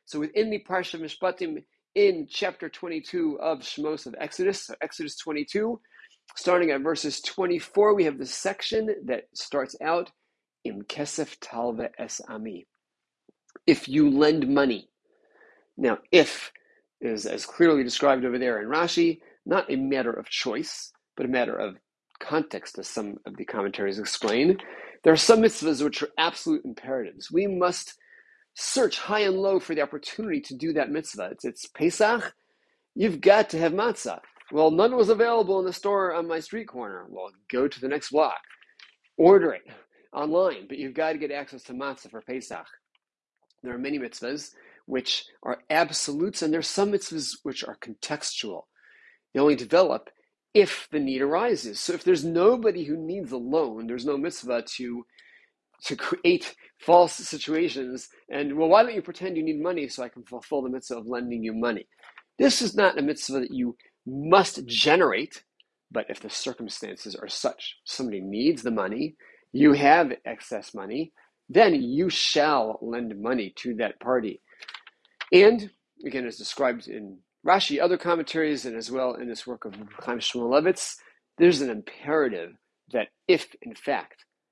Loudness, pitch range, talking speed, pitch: -25 LUFS, 140-230 Hz, 165 wpm, 170 Hz